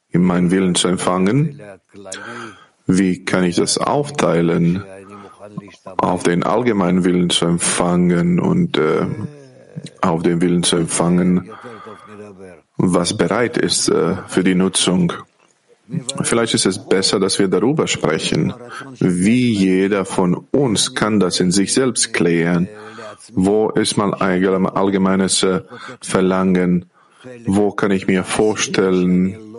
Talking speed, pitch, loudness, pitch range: 120 wpm, 95 Hz, -16 LUFS, 90-110 Hz